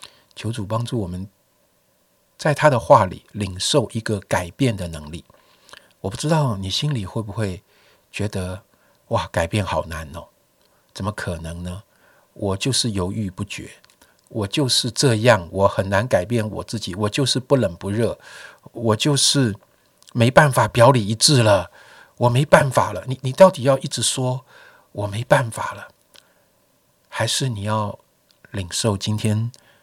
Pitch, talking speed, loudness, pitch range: 110 Hz, 215 characters per minute, -20 LUFS, 100-125 Hz